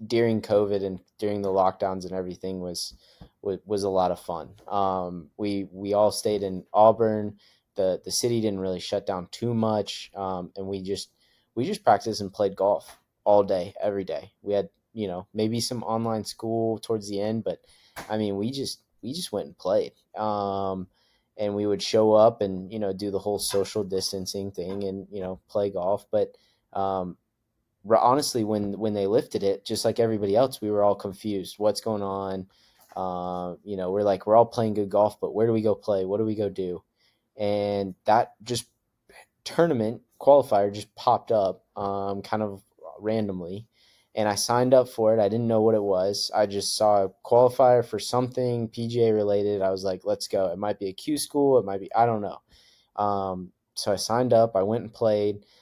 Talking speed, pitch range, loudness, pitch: 200 wpm, 95-110 Hz, -26 LUFS, 105 Hz